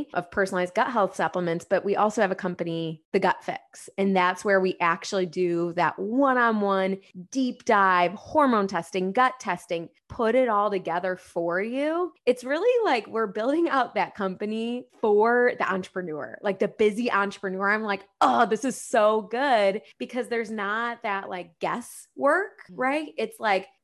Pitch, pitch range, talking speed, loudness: 200 Hz, 185-240 Hz, 170 wpm, -25 LUFS